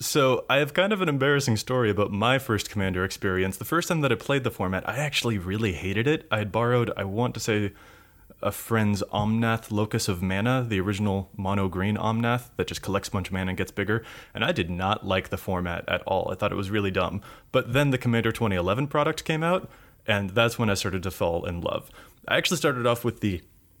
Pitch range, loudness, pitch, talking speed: 95-125 Hz, -26 LUFS, 110 Hz, 230 wpm